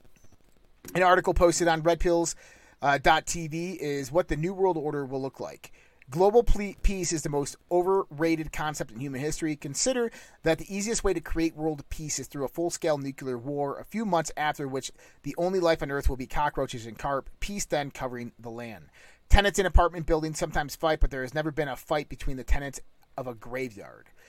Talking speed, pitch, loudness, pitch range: 200 wpm, 155 Hz, -28 LUFS, 135-175 Hz